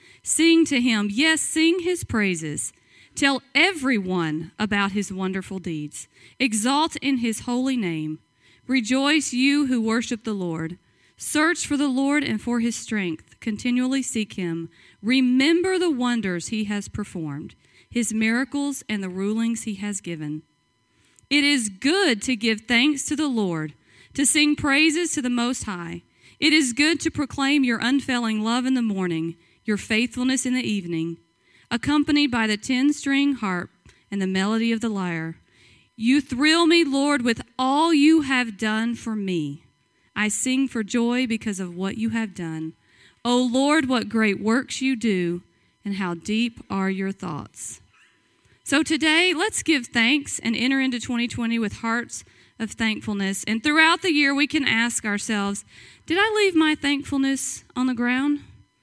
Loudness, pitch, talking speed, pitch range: -22 LUFS, 235 Hz, 160 wpm, 200-280 Hz